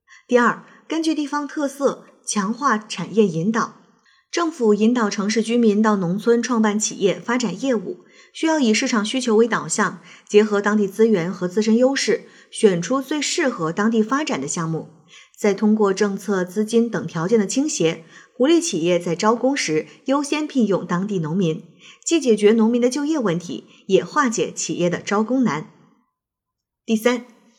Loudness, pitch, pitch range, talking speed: -20 LUFS, 220 Hz, 195-255 Hz, 250 characters per minute